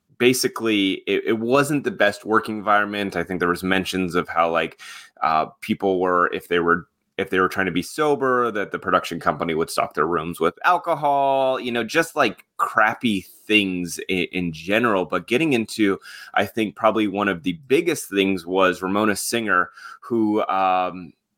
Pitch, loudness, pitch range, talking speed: 100 Hz, -21 LUFS, 90-115 Hz, 180 wpm